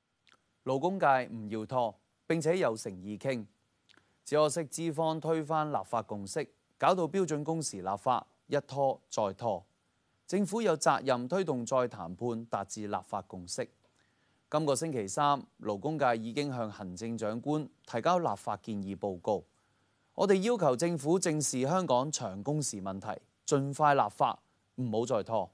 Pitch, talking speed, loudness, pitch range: 130 Hz, 230 characters per minute, -32 LUFS, 105-155 Hz